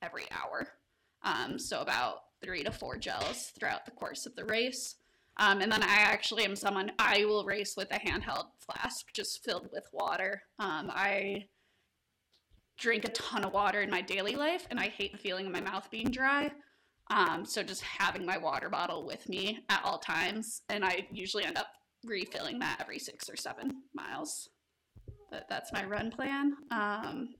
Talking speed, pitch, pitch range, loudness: 185 wpm, 210 Hz, 200-260 Hz, -33 LUFS